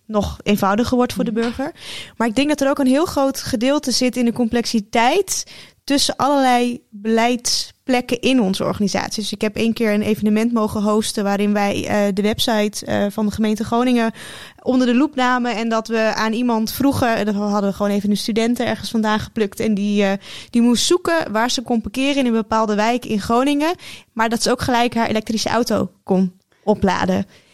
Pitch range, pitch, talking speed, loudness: 215-250 Hz, 225 Hz, 200 wpm, -18 LUFS